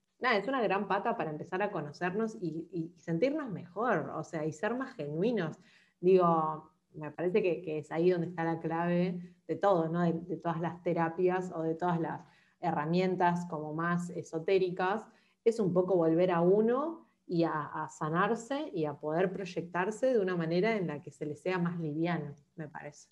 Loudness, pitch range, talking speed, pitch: -32 LUFS, 160-190 Hz, 190 wpm, 170 Hz